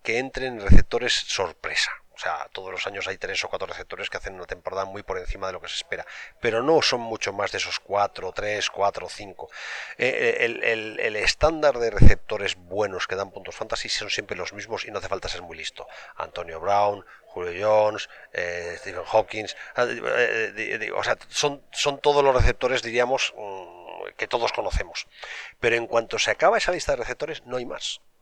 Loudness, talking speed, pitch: -25 LUFS, 190 wpm, 125 Hz